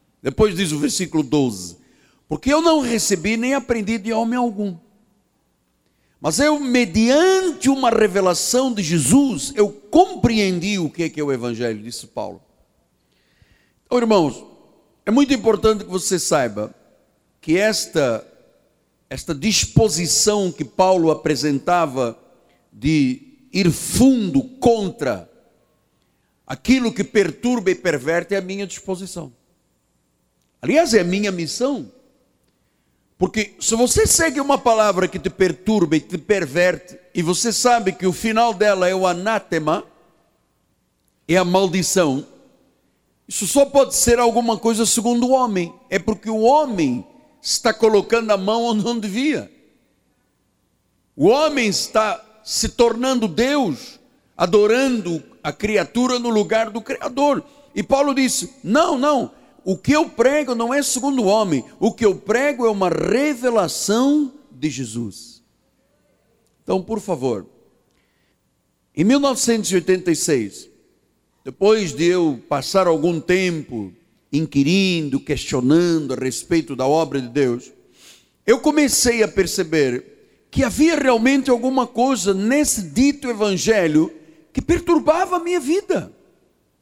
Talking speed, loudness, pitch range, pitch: 125 wpm, -18 LUFS, 175-255 Hz, 215 Hz